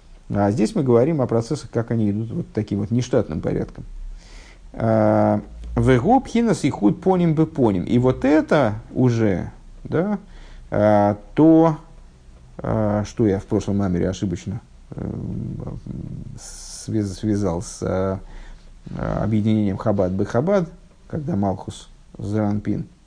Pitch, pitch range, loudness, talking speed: 110 Hz, 100-135 Hz, -21 LUFS, 105 wpm